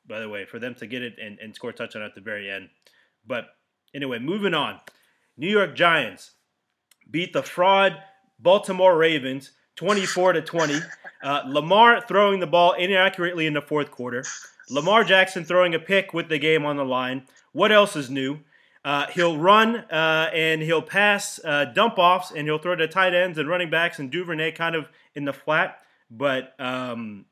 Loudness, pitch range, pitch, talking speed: -21 LUFS, 140-185 Hz, 160 Hz, 185 wpm